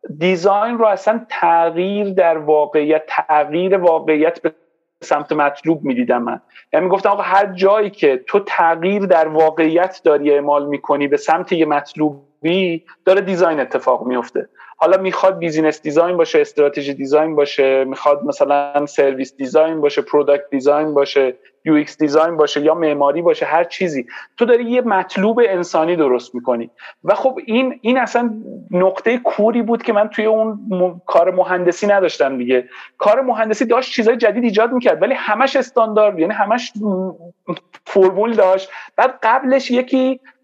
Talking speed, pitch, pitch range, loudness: 150 wpm, 180 Hz, 150-215 Hz, -16 LUFS